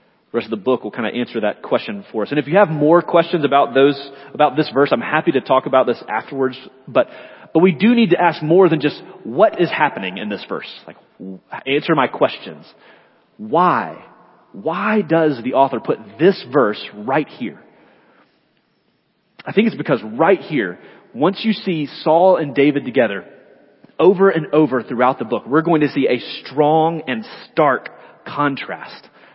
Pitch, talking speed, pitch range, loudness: 150 Hz, 180 wpm, 135-175 Hz, -17 LUFS